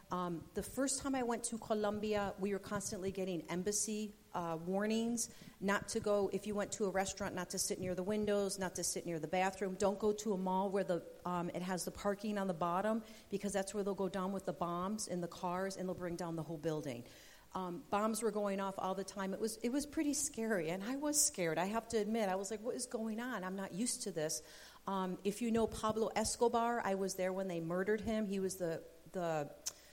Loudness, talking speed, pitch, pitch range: -39 LUFS, 245 wpm, 195 Hz, 180-215 Hz